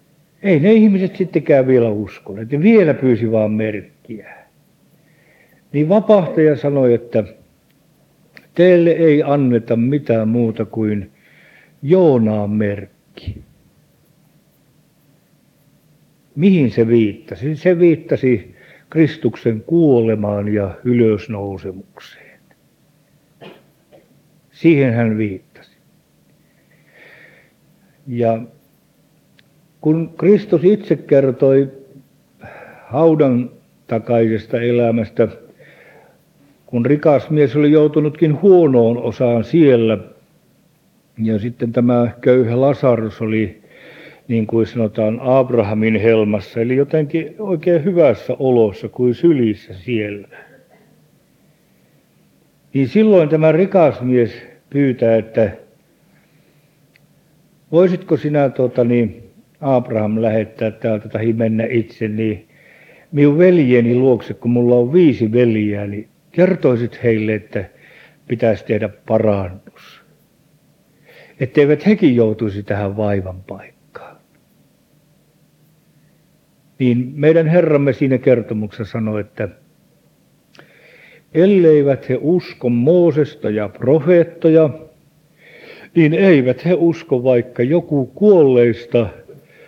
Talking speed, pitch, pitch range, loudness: 85 wpm, 130 Hz, 115-155 Hz, -15 LUFS